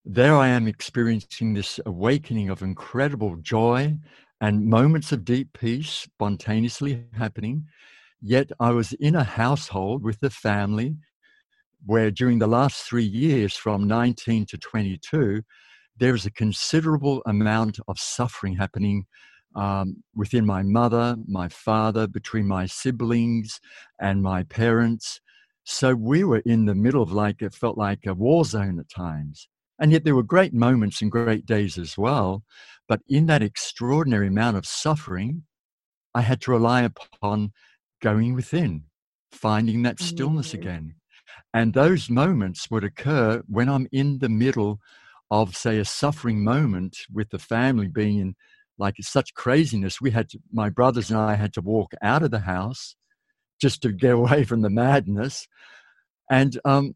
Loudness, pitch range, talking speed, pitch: -23 LUFS, 105-135 Hz, 155 wpm, 115 Hz